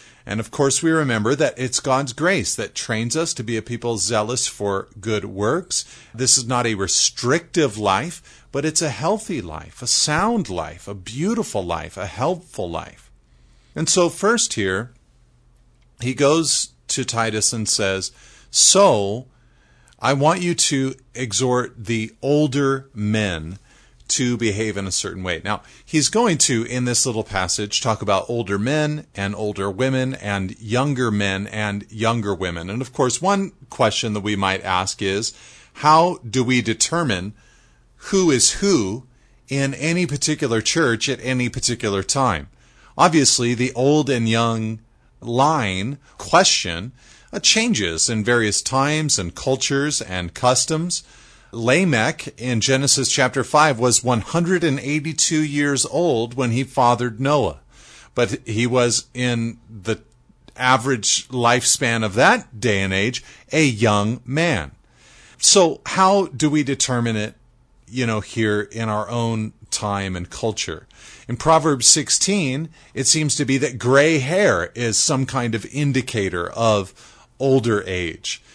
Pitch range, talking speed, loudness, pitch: 105-140 Hz, 145 wpm, -19 LUFS, 120 Hz